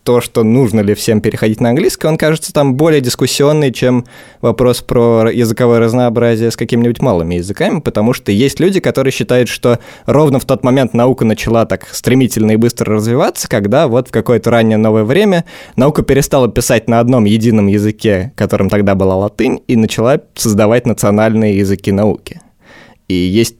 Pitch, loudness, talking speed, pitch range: 115 Hz, -12 LUFS, 170 wpm, 110-130 Hz